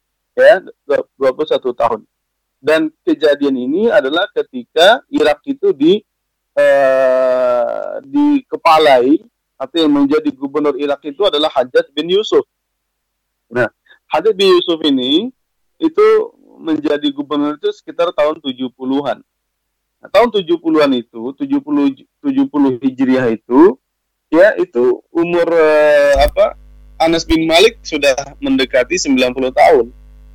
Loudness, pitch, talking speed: -14 LUFS, 170 Hz, 110 wpm